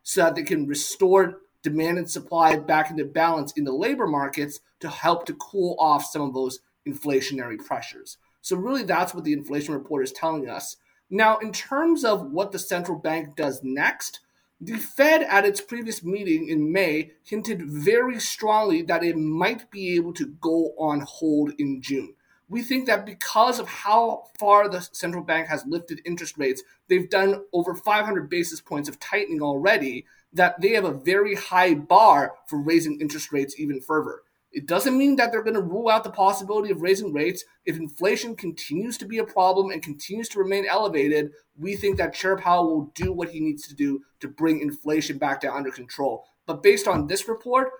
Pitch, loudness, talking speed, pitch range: 180 Hz, -23 LUFS, 190 wpm, 155-220 Hz